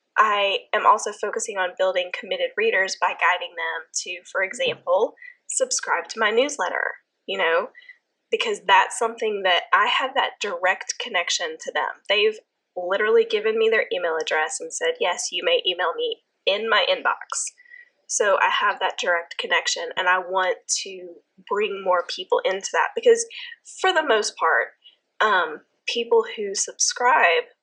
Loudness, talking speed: -22 LUFS, 155 wpm